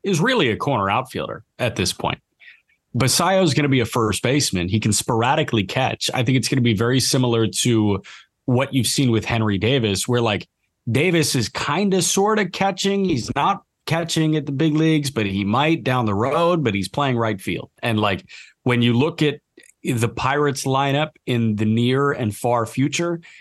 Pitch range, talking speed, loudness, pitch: 115-155 Hz, 195 wpm, -20 LUFS, 130 Hz